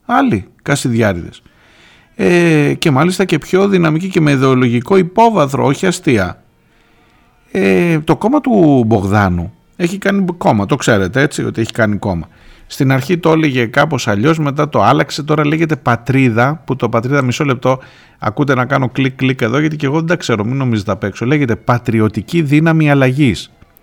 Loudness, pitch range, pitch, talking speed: -13 LUFS, 120-160 Hz, 140 Hz, 165 wpm